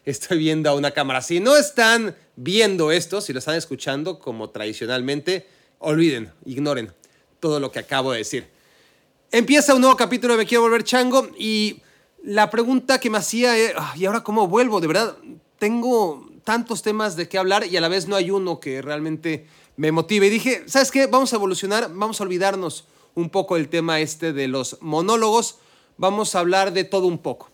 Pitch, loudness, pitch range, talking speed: 190 Hz, -20 LUFS, 155-225 Hz, 190 wpm